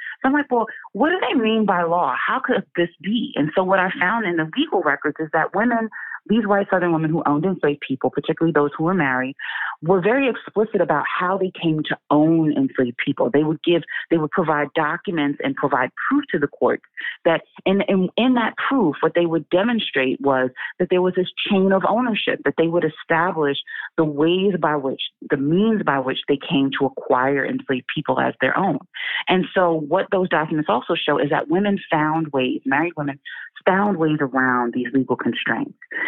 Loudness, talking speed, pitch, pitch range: -20 LUFS, 205 wpm, 165 Hz, 145-195 Hz